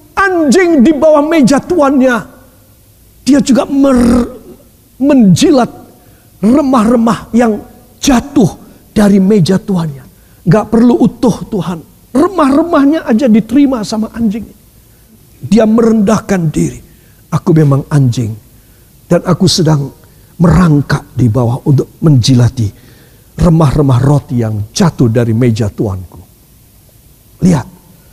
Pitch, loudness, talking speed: 175 Hz, -10 LUFS, 100 wpm